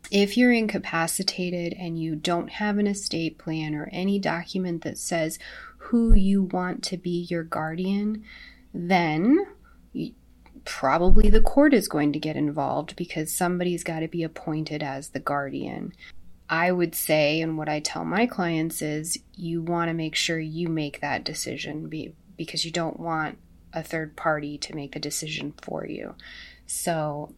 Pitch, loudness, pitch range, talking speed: 165 Hz, -26 LUFS, 155-185 Hz, 165 wpm